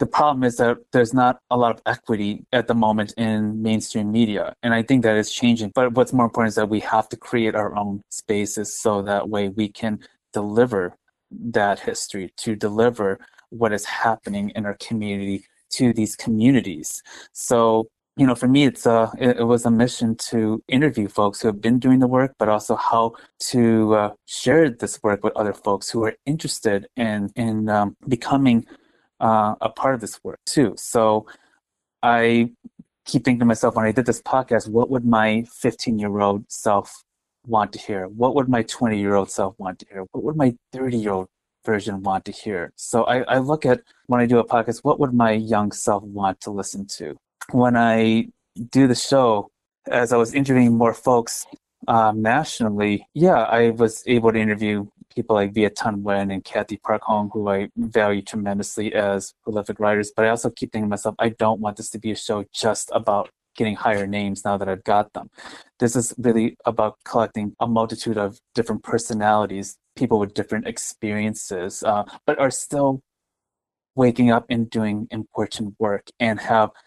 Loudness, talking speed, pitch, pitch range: -21 LUFS, 190 wpm, 110 Hz, 105-120 Hz